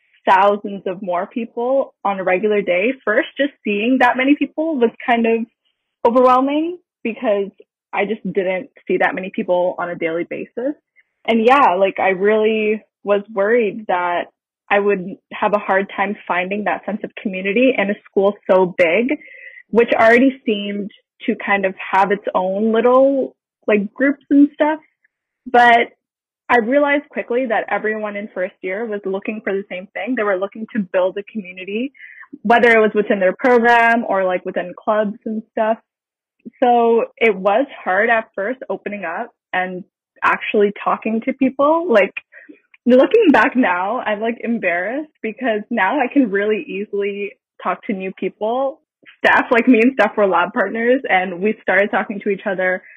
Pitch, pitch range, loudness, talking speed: 220 Hz, 200-250 Hz, -17 LUFS, 165 wpm